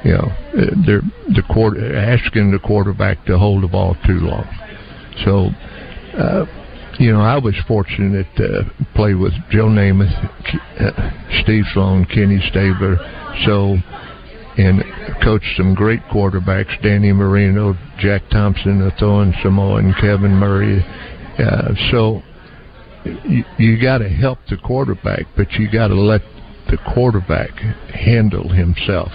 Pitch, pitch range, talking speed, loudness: 100 Hz, 95-110 Hz, 130 wpm, -15 LUFS